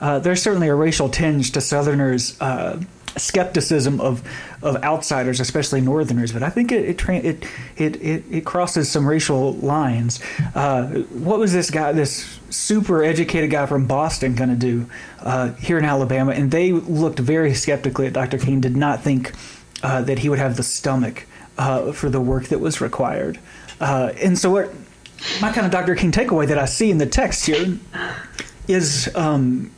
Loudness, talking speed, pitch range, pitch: -20 LUFS, 180 wpm, 130-165 Hz, 145 Hz